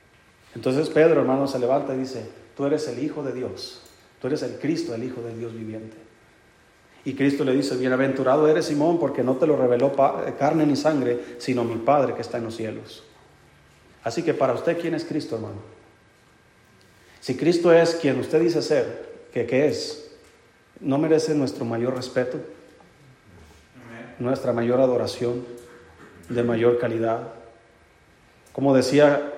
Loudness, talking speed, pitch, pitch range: -23 LUFS, 155 wpm, 130 Hz, 115-150 Hz